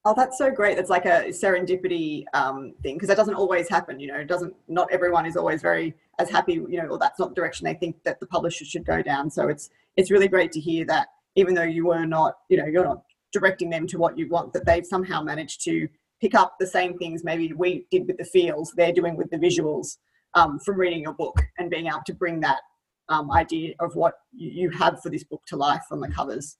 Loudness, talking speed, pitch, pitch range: -24 LUFS, 250 wpm, 175 Hz, 165-190 Hz